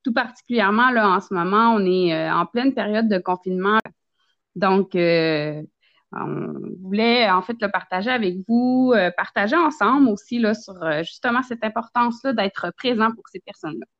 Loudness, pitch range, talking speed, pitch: -20 LUFS, 185-240 Hz, 165 wpm, 210 Hz